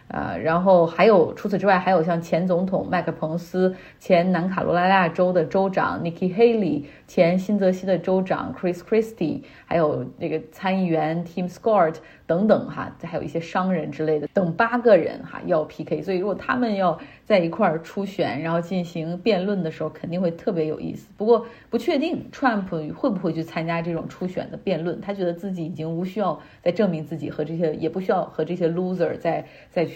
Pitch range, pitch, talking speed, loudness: 165-195 Hz, 180 Hz, 365 characters per minute, -23 LUFS